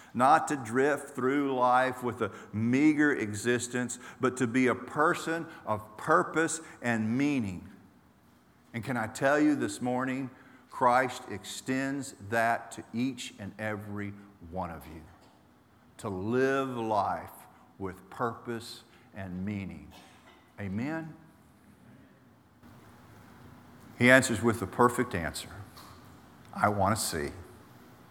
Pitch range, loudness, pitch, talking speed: 105-130 Hz, -30 LUFS, 120 Hz, 115 wpm